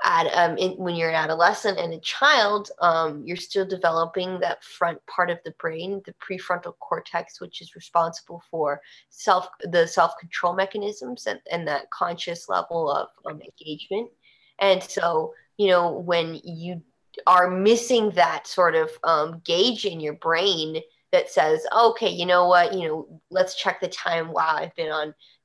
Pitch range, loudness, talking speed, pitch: 165-190 Hz, -23 LUFS, 170 wpm, 175 Hz